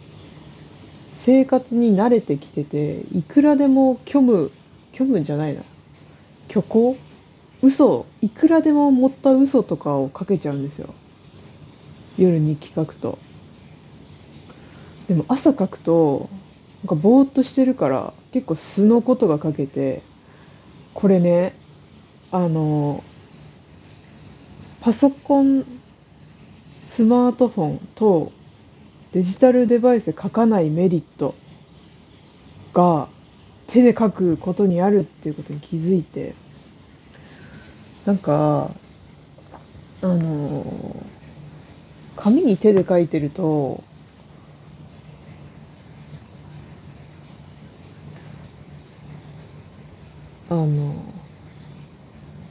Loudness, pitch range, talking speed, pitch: -19 LUFS, 155-250 Hz, 170 characters per minute, 190 Hz